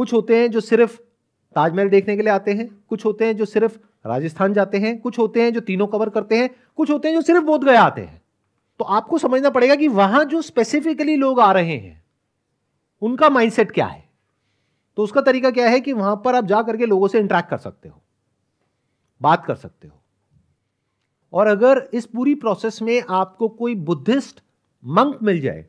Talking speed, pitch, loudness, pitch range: 200 wpm, 225 Hz, -18 LUFS, 200-250 Hz